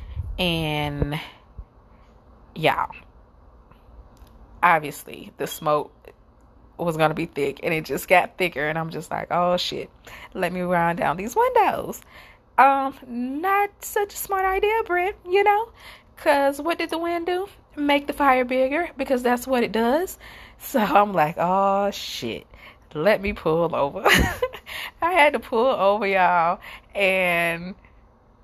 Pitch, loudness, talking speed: 210 Hz, -22 LUFS, 140 wpm